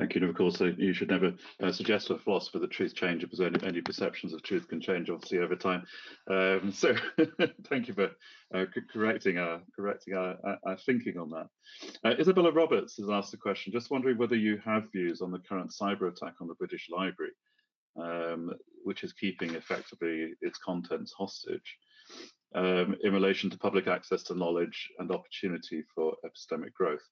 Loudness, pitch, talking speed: -32 LUFS, 105 Hz, 185 wpm